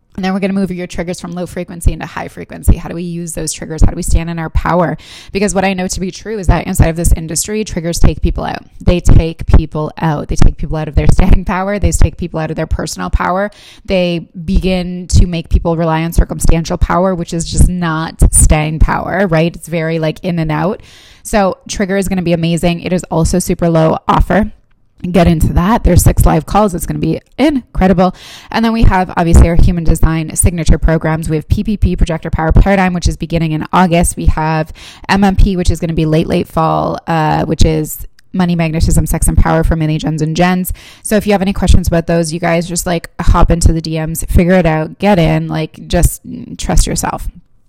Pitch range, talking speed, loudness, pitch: 160-185 Hz, 225 wpm, -14 LUFS, 170 Hz